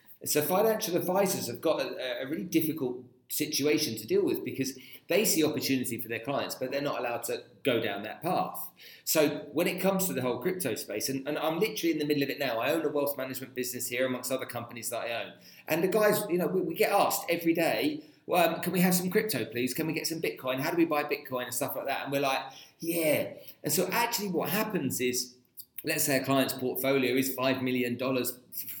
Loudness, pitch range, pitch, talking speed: -30 LUFS, 130-170 Hz, 145 Hz, 235 wpm